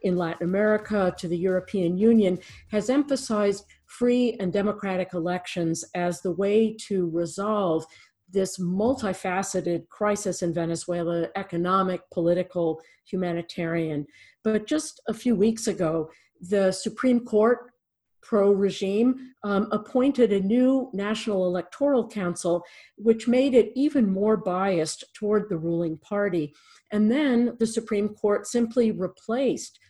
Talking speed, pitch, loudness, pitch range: 120 wpm, 200 Hz, -25 LUFS, 180-225 Hz